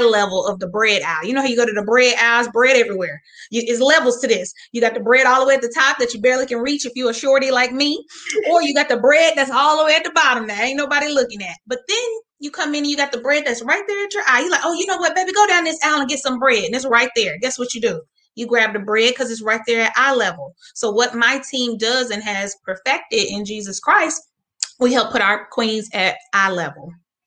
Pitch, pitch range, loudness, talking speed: 250 Hz, 225-290 Hz, -17 LUFS, 285 wpm